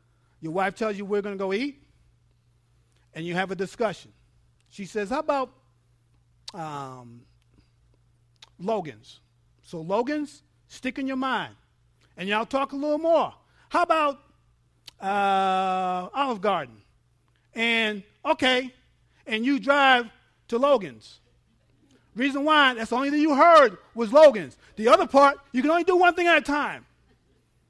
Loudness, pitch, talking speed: -23 LUFS, 205 Hz, 140 wpm